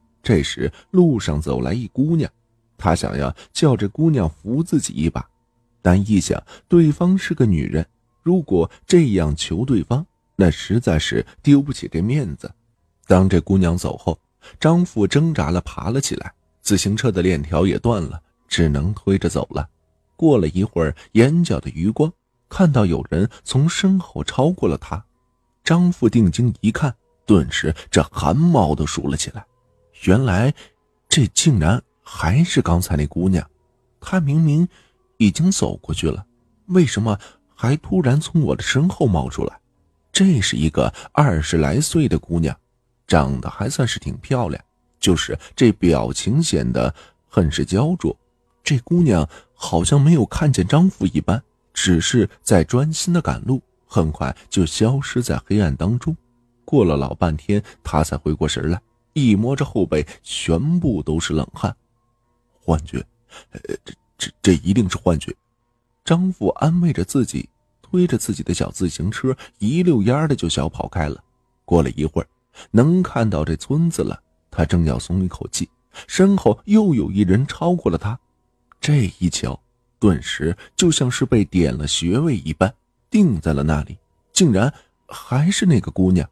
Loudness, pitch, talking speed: -19 LUFS, 110 Hz, 225 characters per minute